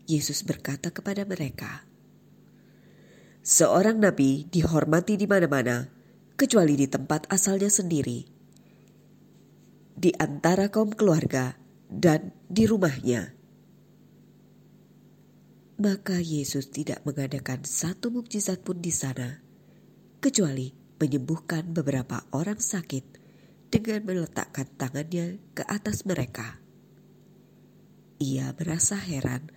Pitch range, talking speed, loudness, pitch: 140-195 Hz, 90 wpm, -26 LUFS, 160 Hz